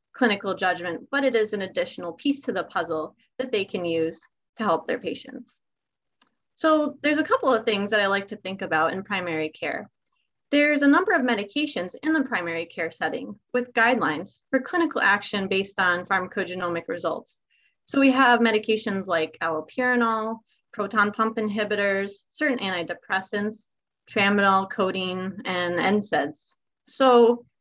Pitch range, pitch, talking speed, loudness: 185-250 Hz, 210 Hz, 150 wpm, -24 LUFS